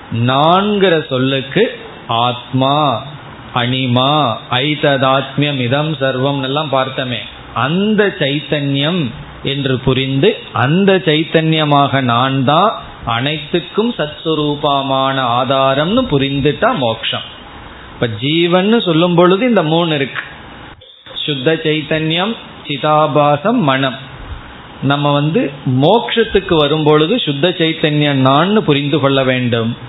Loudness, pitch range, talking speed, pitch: -14 LUFS, 130-160 Hz, 70 wpm, 145 Hz